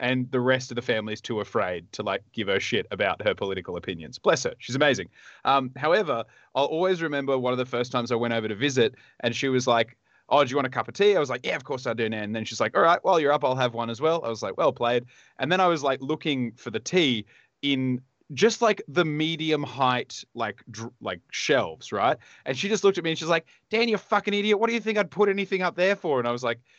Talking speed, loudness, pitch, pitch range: 275 wpm, -25 LUFS, 135 Hz, 120-185 Hz